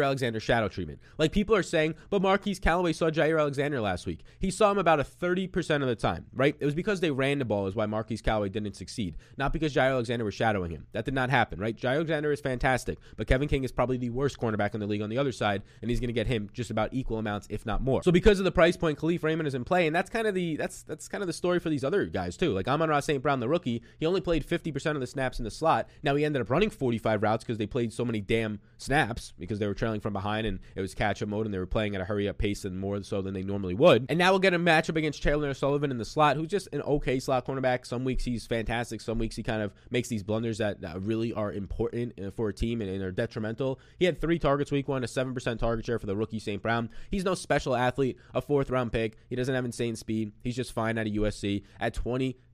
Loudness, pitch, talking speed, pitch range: -29 LUFS, 125 Hz, 280 wpm, 110-150 Hz